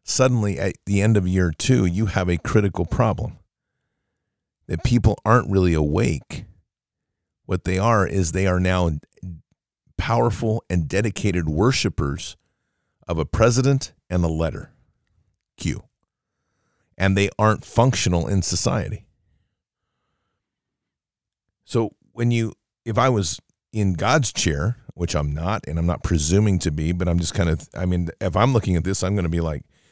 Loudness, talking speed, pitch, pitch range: -21 LUFS, 150 wpm, 95 Hz, 85-110 Hz